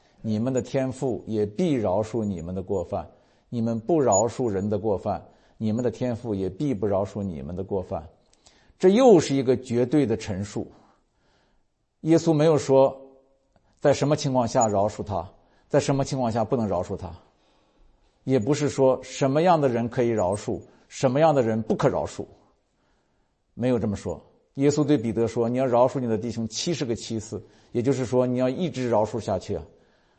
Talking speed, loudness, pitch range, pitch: 260 characters per minute, -24 LUFS, 105-135 Hz, 120 Hz